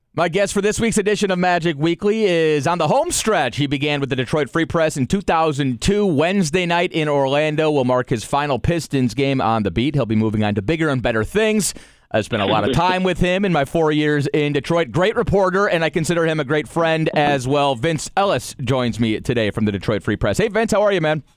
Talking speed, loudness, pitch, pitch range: 240 wpm, -18 LUFS, 155 Hz, 135-180 Hz